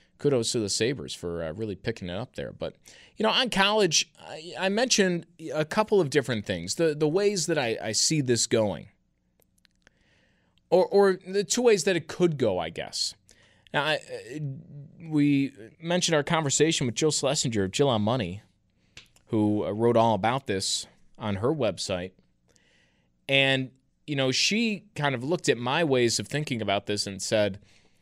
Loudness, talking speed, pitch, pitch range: -26 LUFS, 175 wpm, 140 Hz, 110-170 Hz